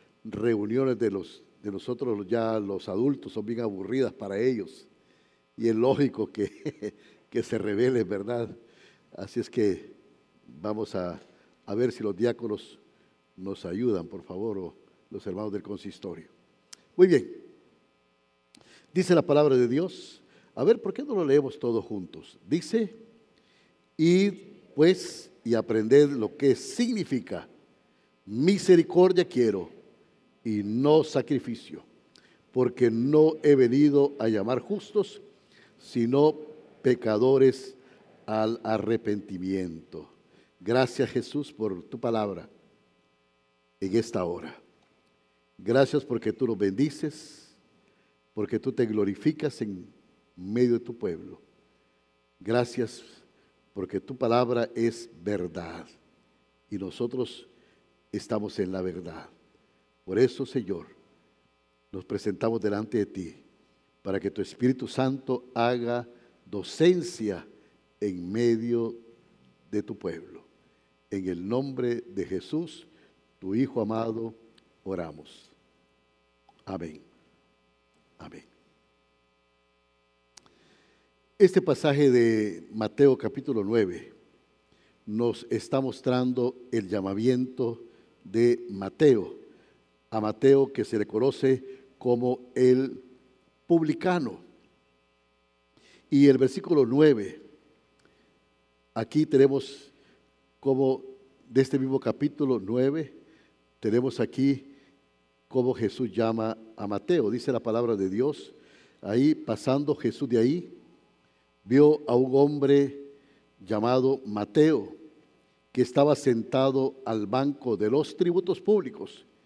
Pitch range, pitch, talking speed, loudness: 85-135 Hz, 115 Hz, 105 wpm, -27 LUFS